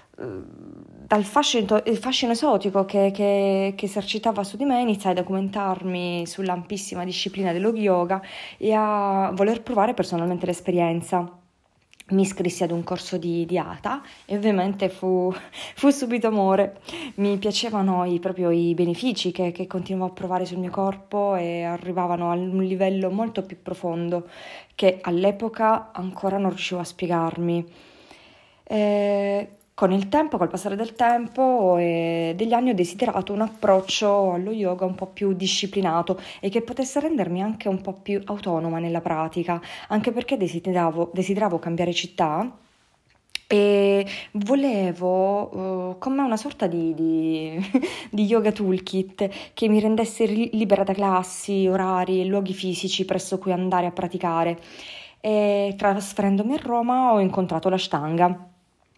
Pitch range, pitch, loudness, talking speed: 180-210 Hz, 195 Hz, -23 LUFS, 140 wpm